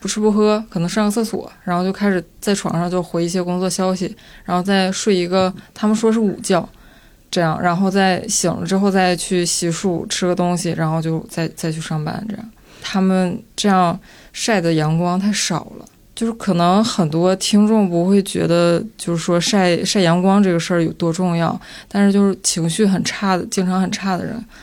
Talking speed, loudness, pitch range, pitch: 290 characters per minute, -18 LUFS, 175-200 Hz, 185 Hz